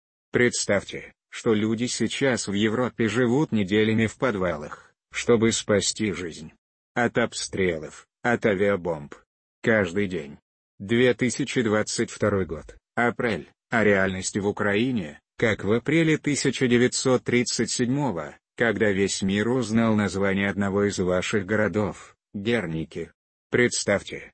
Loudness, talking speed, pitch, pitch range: -24 LUFS, 105 wpm, 110 Hz, 100-120 Hz